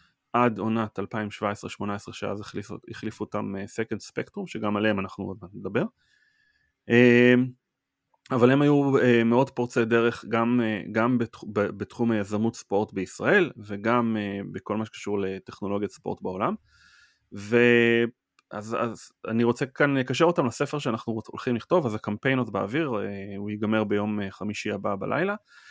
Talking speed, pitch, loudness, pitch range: 150 wpm, 115 Hz, -26 LUFS, 105-120 Hz